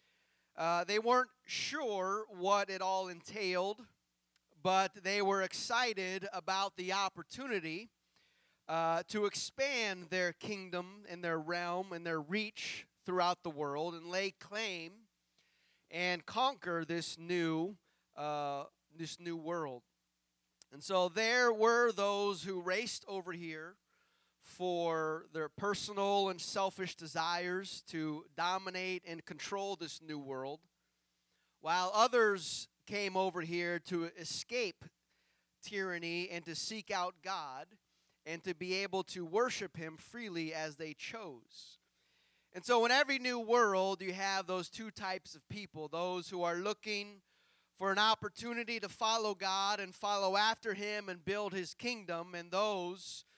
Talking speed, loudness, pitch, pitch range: 135 wpm, -37 LUFS, 185 Hz, 165-205 Hz